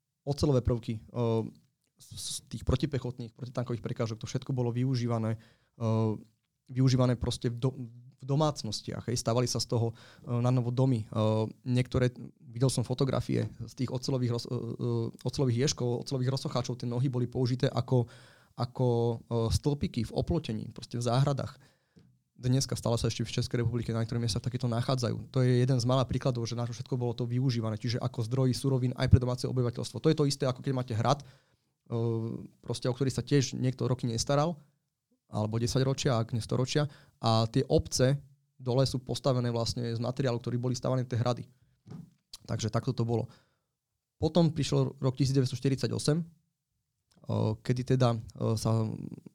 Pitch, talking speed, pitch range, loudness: 125 Hz, 155 wpm, 120-135 Hz, -31 LUFS